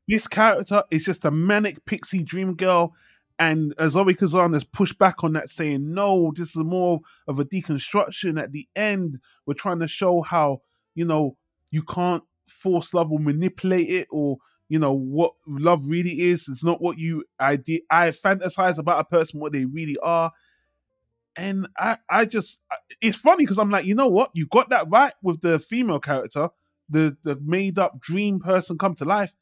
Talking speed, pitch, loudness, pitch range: 185 wpm, 170 Hz, -22 LUFS, 155-190 Hz